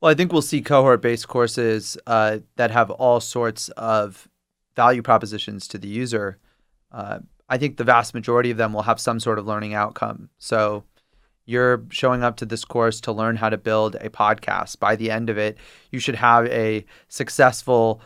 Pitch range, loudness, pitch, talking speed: 110-120 Hz, -21 LUFS, 115 Hz, 195 wpm